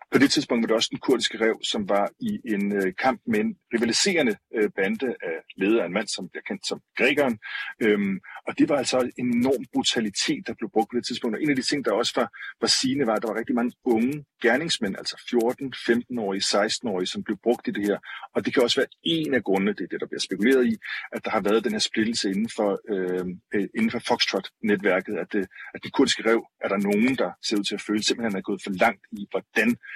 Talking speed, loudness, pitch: 245 wpm, -25 LUFS, 120 Hz